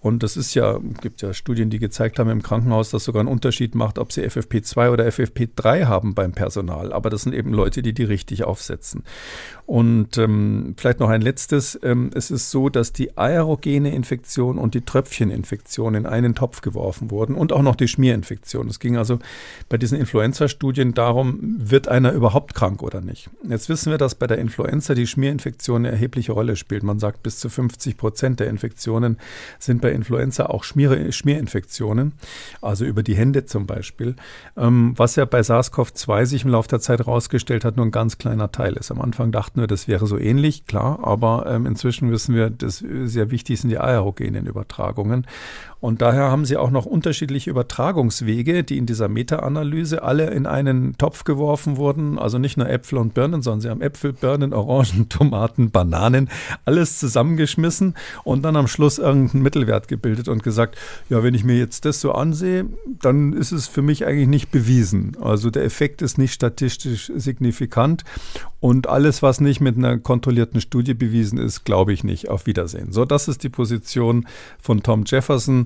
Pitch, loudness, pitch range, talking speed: 120 Hz, -20 LUFS, 115-135 Hz, 185 wpm